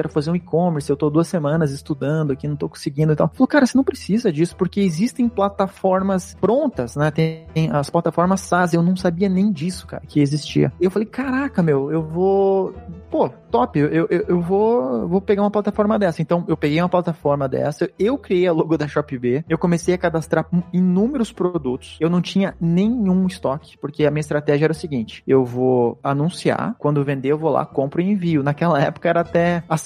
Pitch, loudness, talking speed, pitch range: 170 Hz, -19 LUFS, 205 wpm, 150-190 Hz